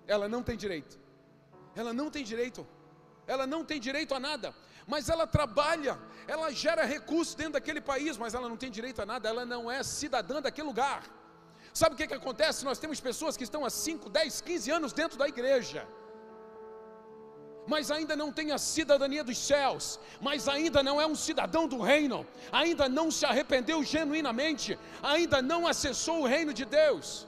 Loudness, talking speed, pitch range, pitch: -31 LUFS, 180 wpm, 245-310 Hz, 280 Hz